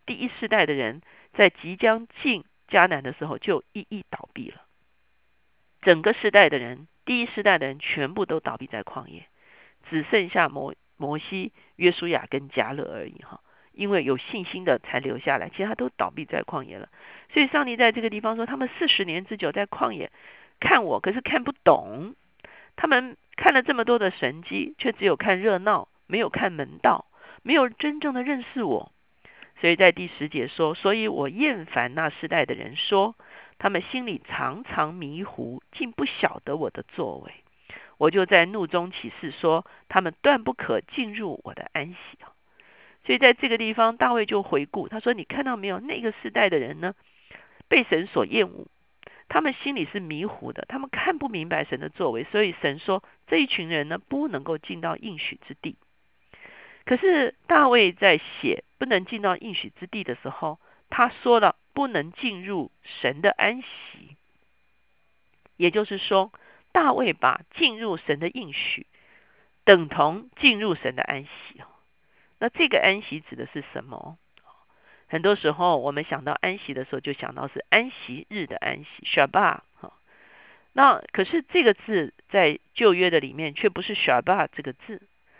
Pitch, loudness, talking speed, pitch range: 205 Hz, -24 LUFS, 260 characters per minute, 160-250 Hz